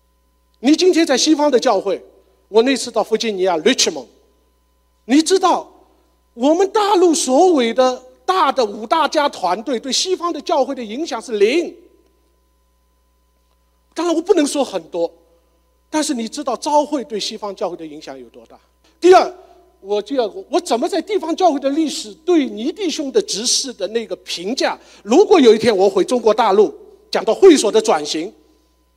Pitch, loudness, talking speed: 260 Hz, -16 LUFS, 260 characters per minute